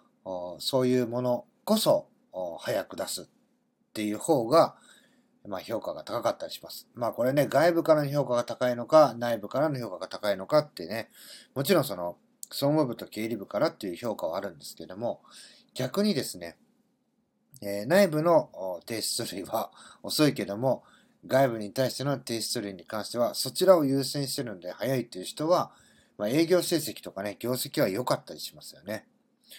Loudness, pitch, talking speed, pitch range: -28 LUFS, 130 Hz, 330 characters per minute, 110-165 Hz